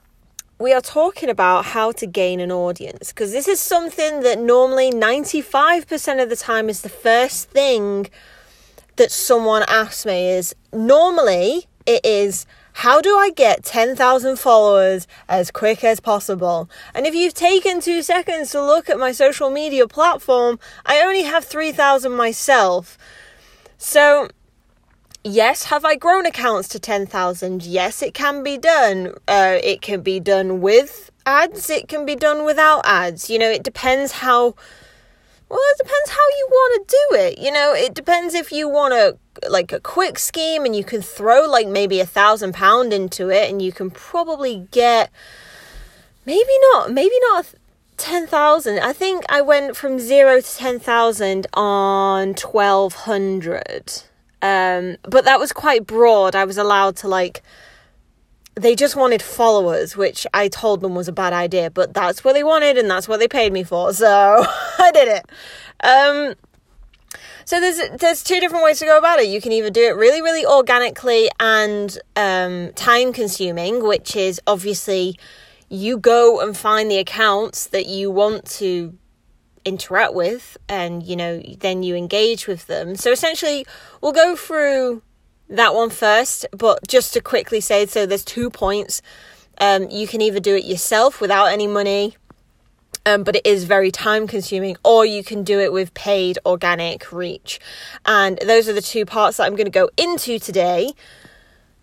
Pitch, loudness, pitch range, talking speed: 225 Hz, -16 LUFS, 195-295 Hz, 170 wpm